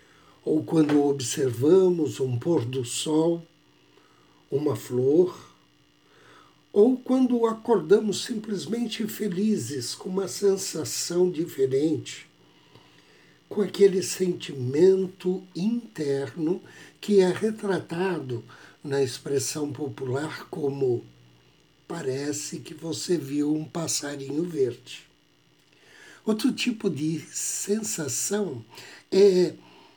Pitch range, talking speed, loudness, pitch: 145-200 Hz, 80 wpm, -26 LUFS, 170 Hz